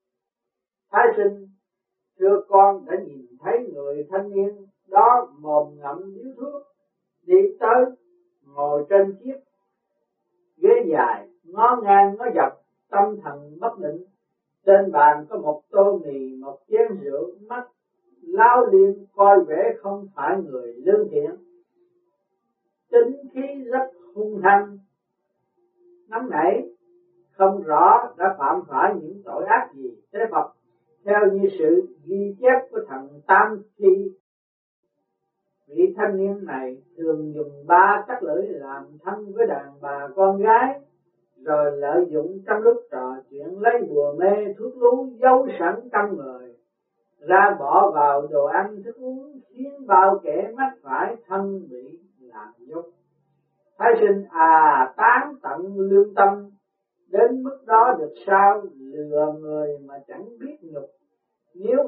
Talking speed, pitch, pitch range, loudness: 140 wpm, 200 Hz, 155-255 Hz, -20 LUFS